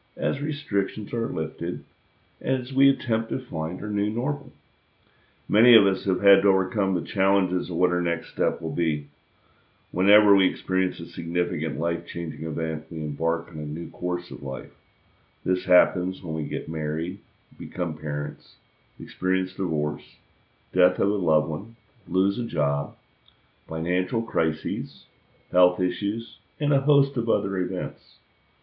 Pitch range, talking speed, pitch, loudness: 80-100 Hz, 150 wpm, 90 Hz, -25 LUFS